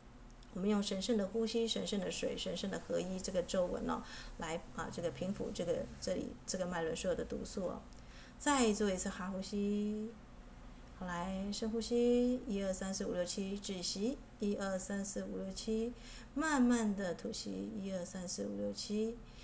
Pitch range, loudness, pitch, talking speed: 185-225 Hz, -38 LUFS, 200 Hz, 255 characters per minute